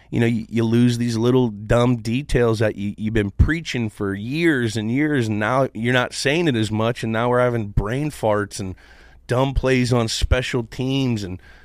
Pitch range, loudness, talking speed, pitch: 110-130 Hz, -20 LUFS, 200 wpm, 120 Hz